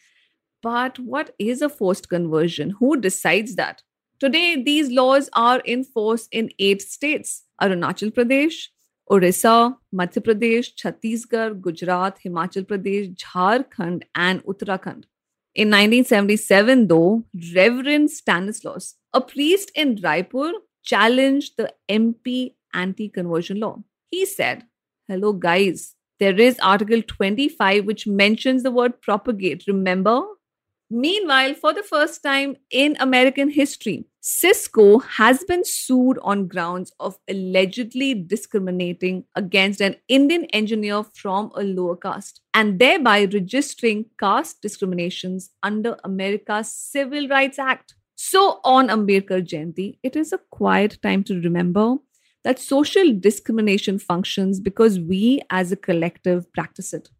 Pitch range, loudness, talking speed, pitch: 190-260 Hz, -19 LUFS, 120 wpm, 215 Hz